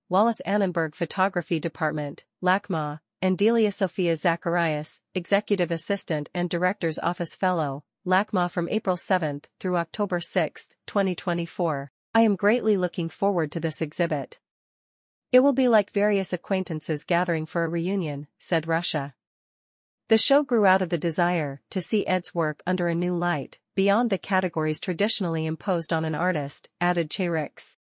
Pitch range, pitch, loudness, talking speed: 160-195 Hz, 175 Hz, -25 LUFS, 150 wpm